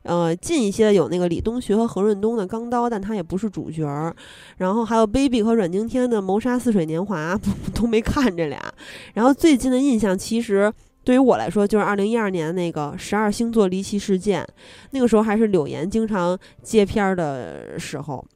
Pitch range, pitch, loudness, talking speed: 185-230 Hz, 210 Hz, -21 LUFS, 315 characters per minute